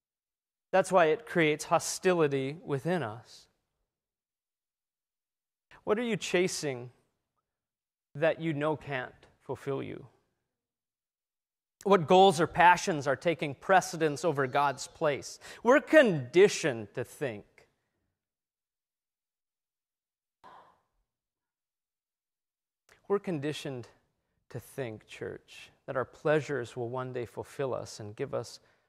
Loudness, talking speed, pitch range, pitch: -29 LUFS, 100 wpm, 125-175 Hz, 150 Hz